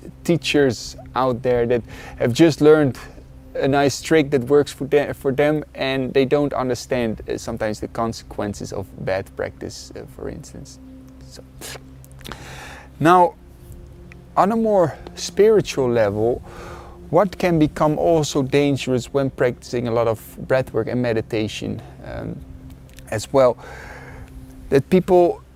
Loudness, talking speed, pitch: -20 LUFS, 130 wpm, 125 Hz